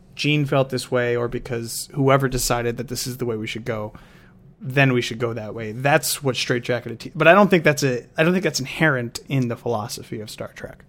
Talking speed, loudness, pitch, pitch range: 240 wpm, -21 LUFS, 125 Hz, 120-145 Hz